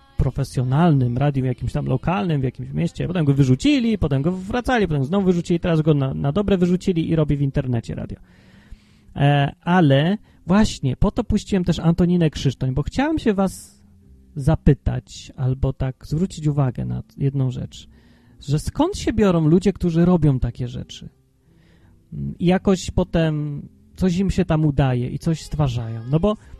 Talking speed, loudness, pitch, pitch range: 160 wpm, -20 LUFS, 150 Hz, 130-180 Hz